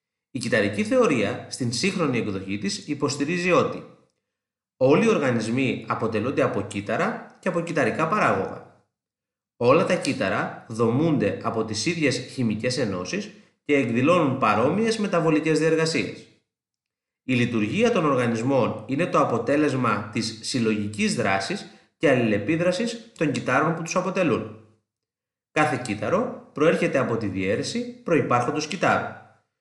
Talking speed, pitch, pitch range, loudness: 120 wpm, 145 Hz, 115-180 Hz, -23 LUFS